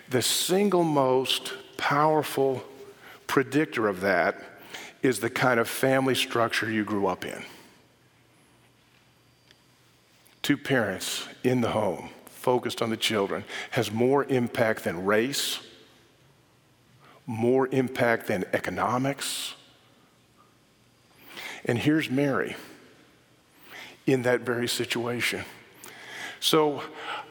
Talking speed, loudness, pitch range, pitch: 95 wpm, -26 LUFS, 115-135 Hz, 125 Hz